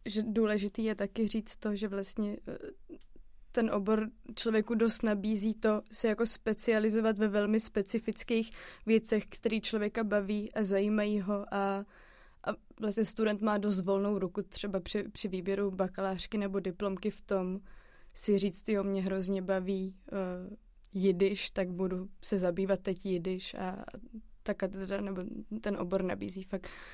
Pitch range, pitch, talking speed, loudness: 195-220 Hz, 205 Hz, 145 wpm, -33 LUFS